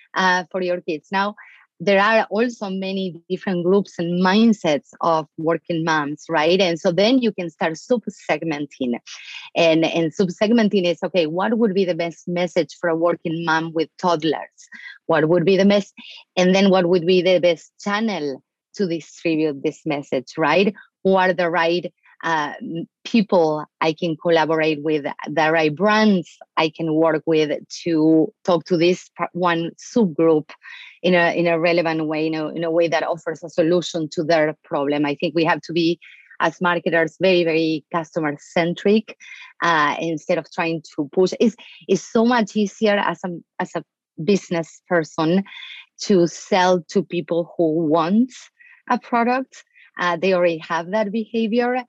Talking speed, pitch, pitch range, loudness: 170 wpm, 175 Hz, 160-195 Hz, -20 LUFS